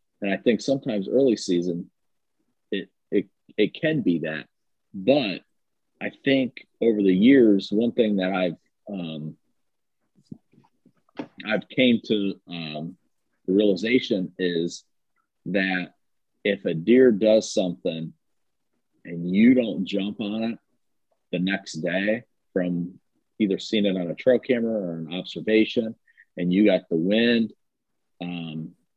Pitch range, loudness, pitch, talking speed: 85-110 Hz, -24 LUFS, 95 Hz, 130 wpm